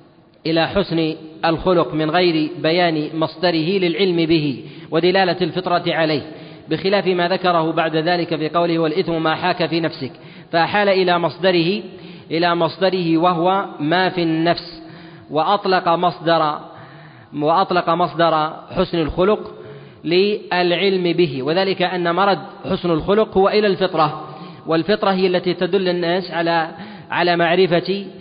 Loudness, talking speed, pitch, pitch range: -18 LUFS, 120 wpm, 170 Hz, 160-185 Hz